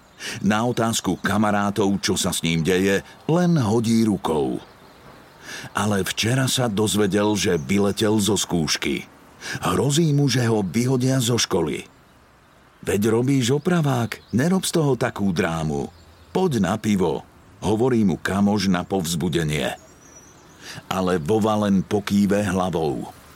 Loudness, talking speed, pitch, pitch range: -21 LUFS, 120 wpm, 105 Hz, 100-125 Hz